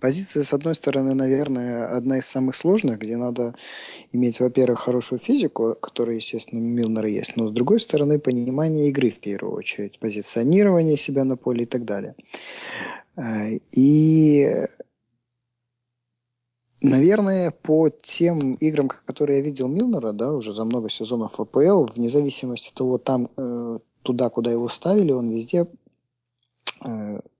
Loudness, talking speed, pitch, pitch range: -22 LUFS, 135 wpm, 125 Hz, 120-145 Hz